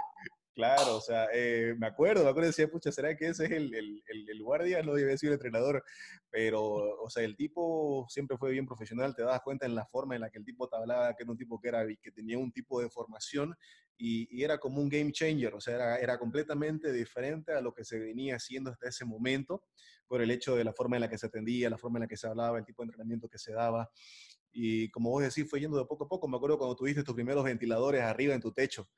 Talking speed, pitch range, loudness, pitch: 265 wpm, 115-145 Hz, -34 LUFS, 125 Hz